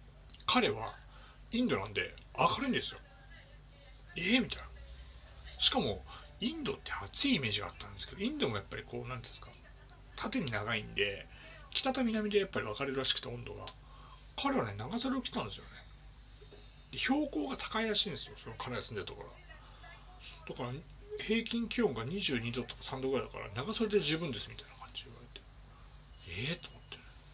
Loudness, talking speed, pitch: -29 LUFS, 365 characters per minute, 135 Hz